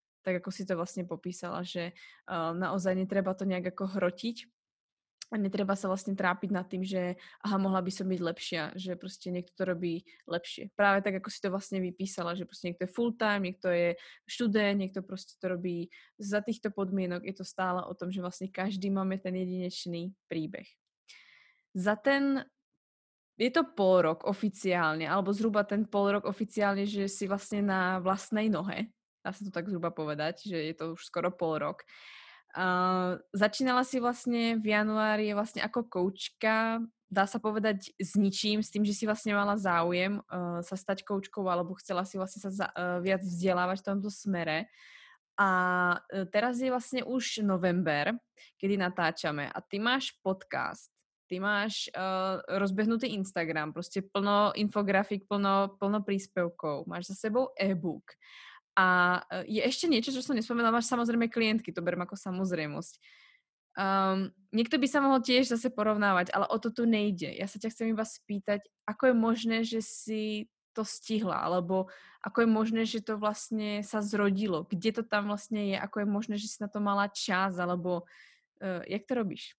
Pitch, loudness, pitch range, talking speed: 195 Hz, -31 LUFS, 180-215 Hz, 175 wpm